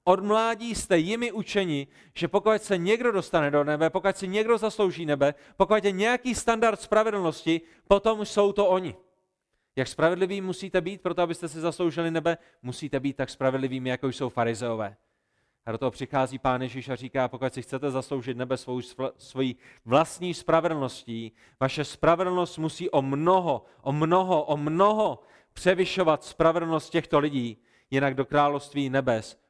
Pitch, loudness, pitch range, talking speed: 160 Hz, -26 LUFS, 130-190 Hz, 155 wpm